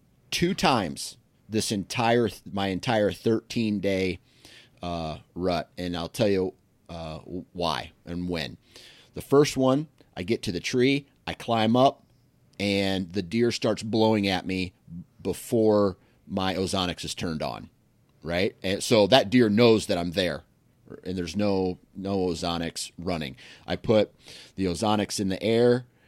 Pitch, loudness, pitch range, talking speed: 100 Hz, -26 LUFS, 90-120 Hz, 145 wpm